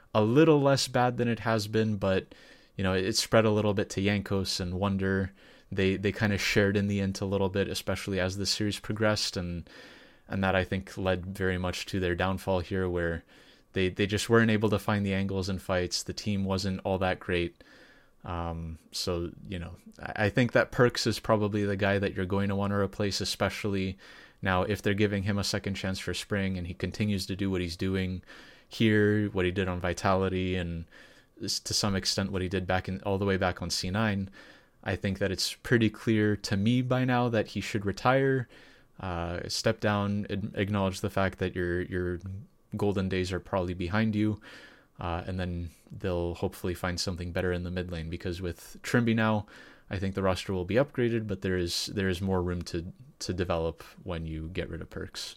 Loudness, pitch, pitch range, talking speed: -29 LUFS, 95 Hz, 90-105 Hz, 210 wpm